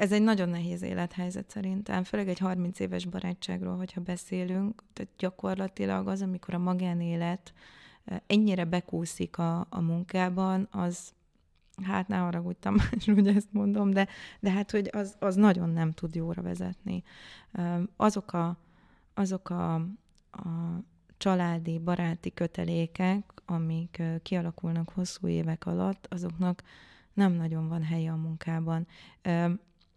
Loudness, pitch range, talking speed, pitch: -31 LUFS, 170-195 Hz, 125 wpm, 180 Hz